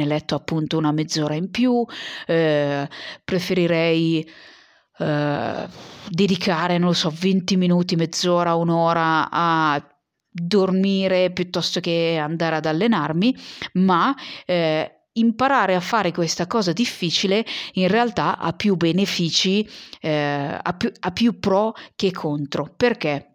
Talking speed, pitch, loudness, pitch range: 115 wpm, 175 Hz, -21 LUFS, 160-195 Hz